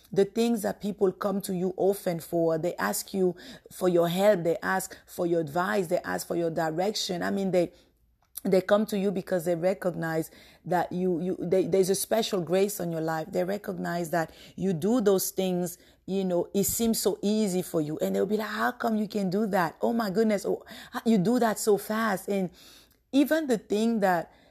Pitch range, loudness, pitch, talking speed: 175-210 Hz, -27 LUFS, 190 Hz, 210 wpm